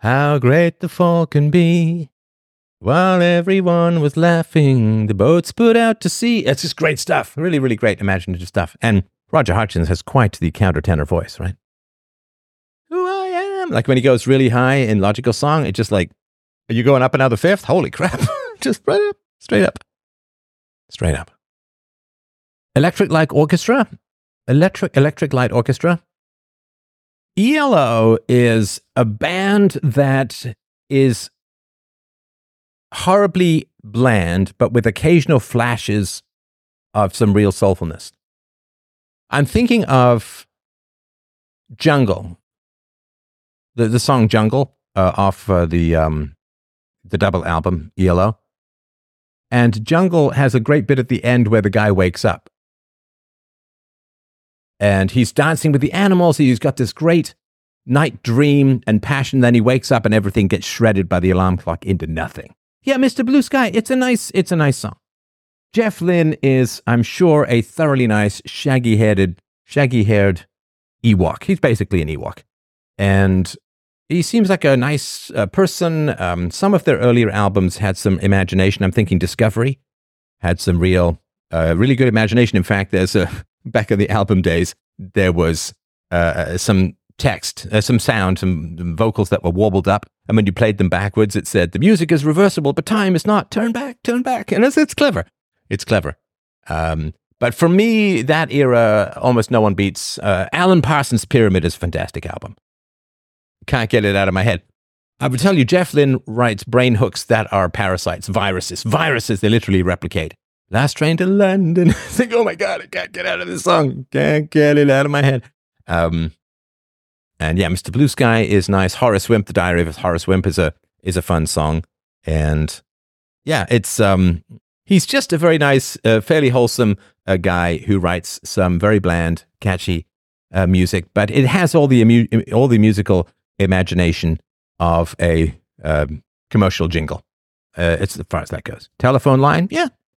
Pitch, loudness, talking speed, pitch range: 115 Hz, -16 LUFS, 165 wpm, 95-145 Hz